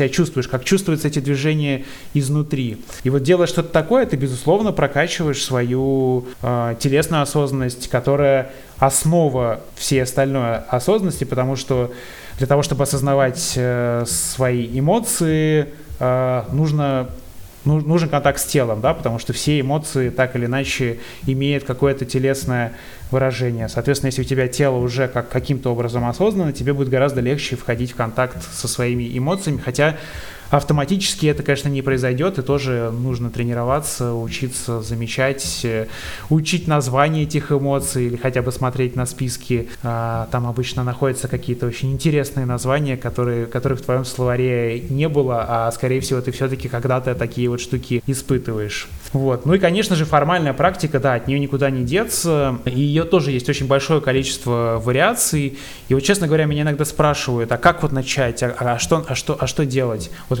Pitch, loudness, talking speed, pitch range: 130 Hz, -19 LUFS, 155 wpm, 125-145 Hz